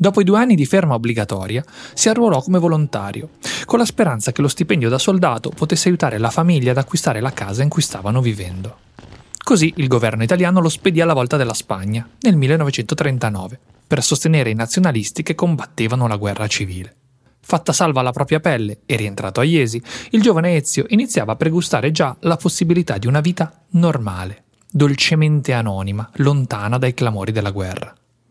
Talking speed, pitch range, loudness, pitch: 170 wpm, 115-170 Hz, -17 LUFS, 140 Hz